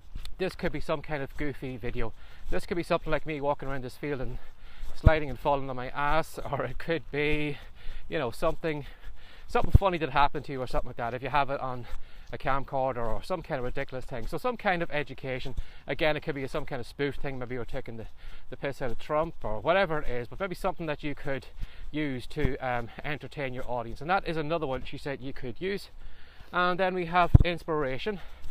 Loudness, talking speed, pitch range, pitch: -31 LUFS, 230 wpm, 120-155 Hz, 140 Hz